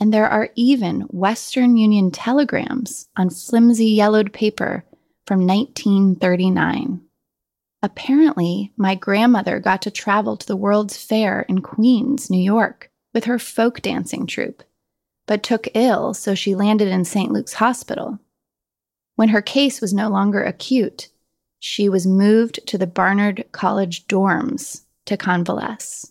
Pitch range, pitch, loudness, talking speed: 195-235 Hz, 210 Hz, -18 LUFS, 135 wpm